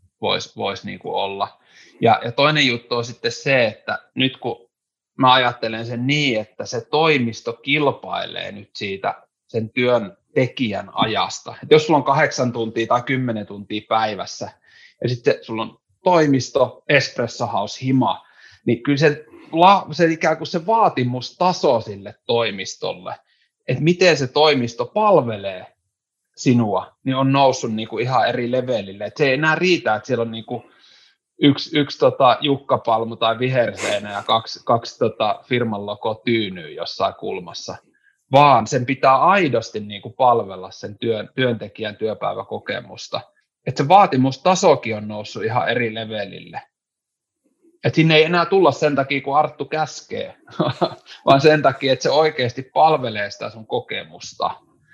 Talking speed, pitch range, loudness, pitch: 145 wpm, 110-150 Hz, -19 LUFS, 125 Hz